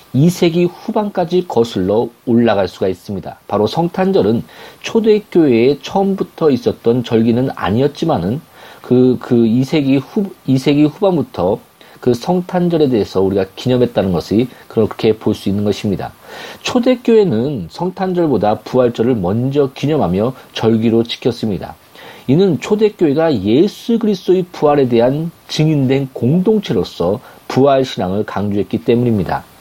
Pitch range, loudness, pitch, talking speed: 115-180 Hz, -15 LUFS, 135 Hz, 310 characters per minute